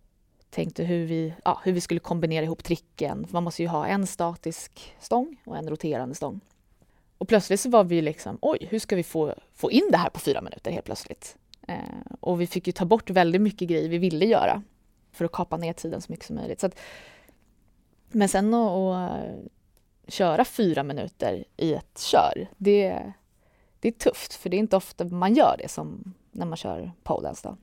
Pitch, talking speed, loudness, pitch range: 180 Hz, 200 wpm, -26 LUFS, 165-205 Hz